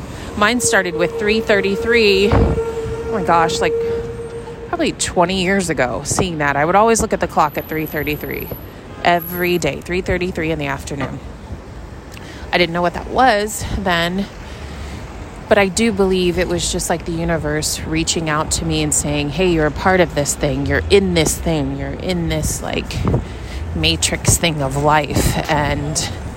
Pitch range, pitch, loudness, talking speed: 150-195 Hz, 175 Hz, -17 LUFS, 165 wpm